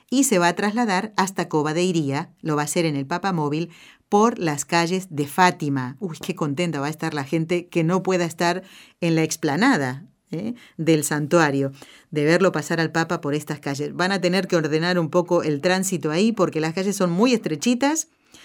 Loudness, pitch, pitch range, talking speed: -22 LUFS, 175 Hz, 155-185 Hz, 200 wpm